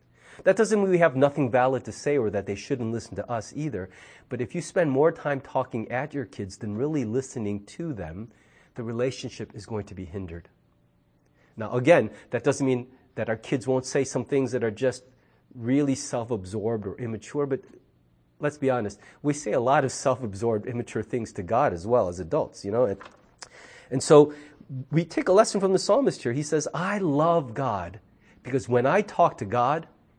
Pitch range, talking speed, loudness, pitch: 110-145 Hz, 200 wpm, -26 LUFS, 130 Hz